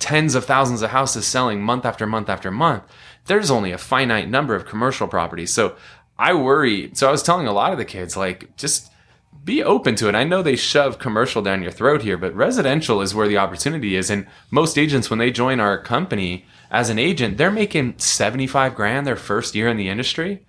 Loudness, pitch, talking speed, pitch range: -19 LUFS, 115 Hz, 215 wpm, 100-130 Hz